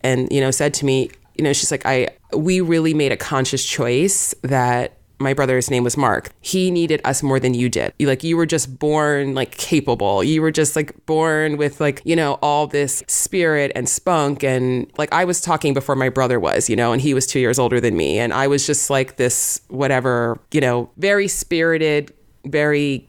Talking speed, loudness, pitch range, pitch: 215 wpm, -18 LUFS, 130-155 Hz, 140 Hz